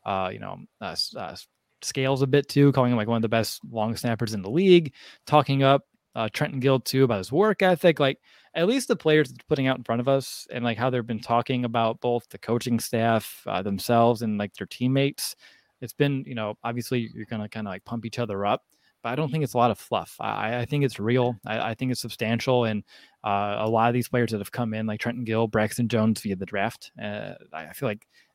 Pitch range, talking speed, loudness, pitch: 110-135 Hz, 245 wpm, -25 LUFS, 120 Hz